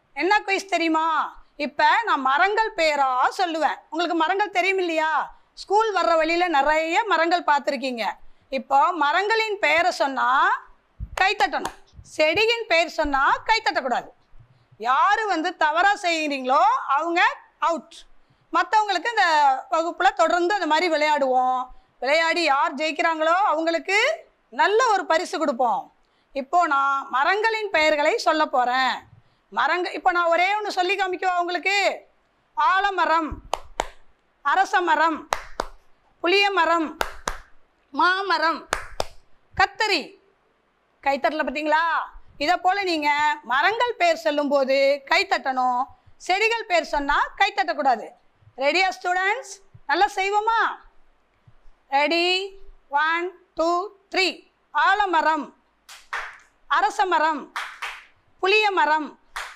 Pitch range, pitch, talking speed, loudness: 305-385 Hz, 335 Hz, 90 wpm, -21 LUFS